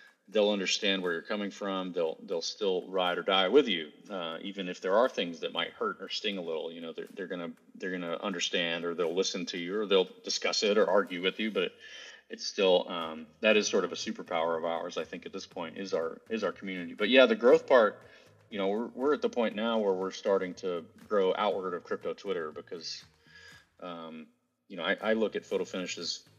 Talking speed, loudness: 235 wpm, -30 LUFS